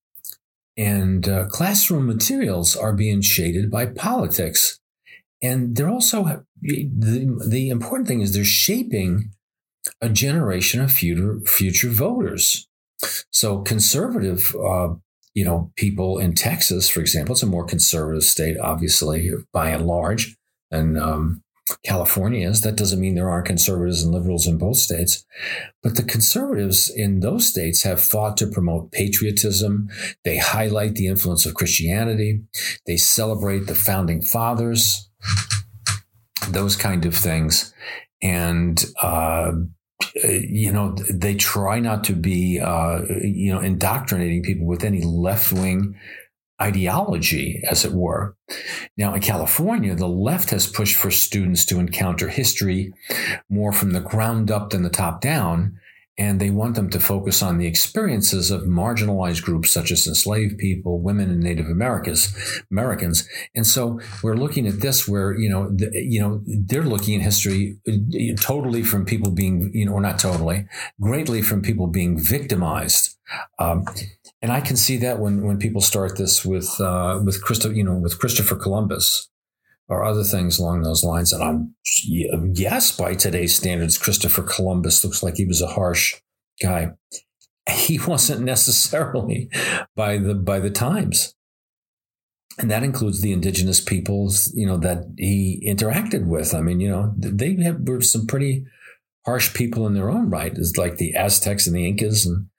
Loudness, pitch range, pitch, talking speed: -19 LUFS, 90-110 Hz, 100 Hz, 155 wpm